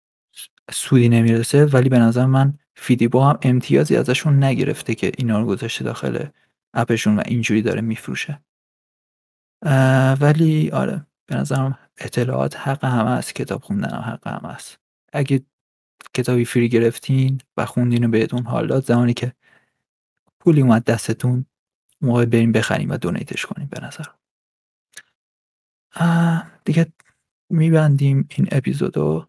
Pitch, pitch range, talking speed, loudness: 125 Hz, 115-140 Hz, 130 wpm, -19 LUFS